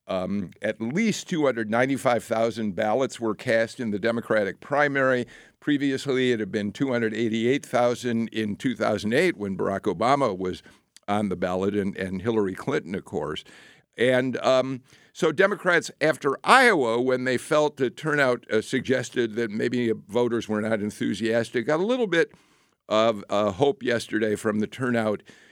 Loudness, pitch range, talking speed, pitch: -25 LUFS, 110-130 Hz, 145 wpm, 115 Hz